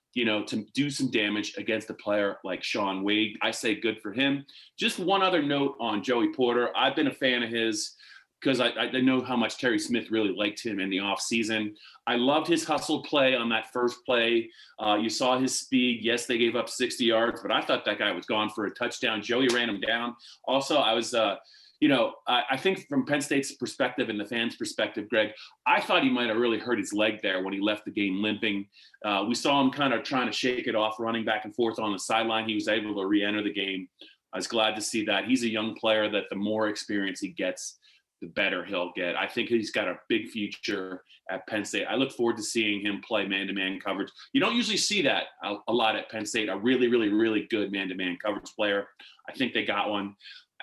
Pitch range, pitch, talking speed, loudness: 105-130 Hz, 115 Hz, 245 wpm, -27 LUFS